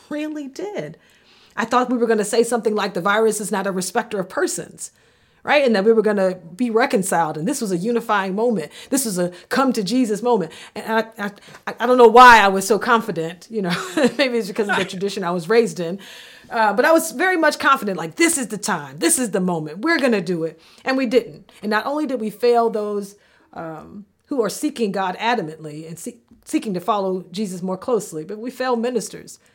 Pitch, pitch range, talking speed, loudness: 220 Hz, 190-245 Hz, 230 wpm, -19 LUFS